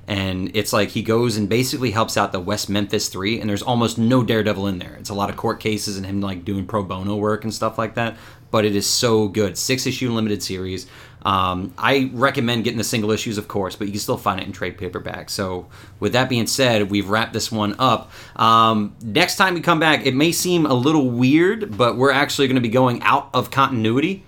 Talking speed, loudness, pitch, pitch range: 235 wpm, -19 LUFS, 110 Hz, 105-125 Hz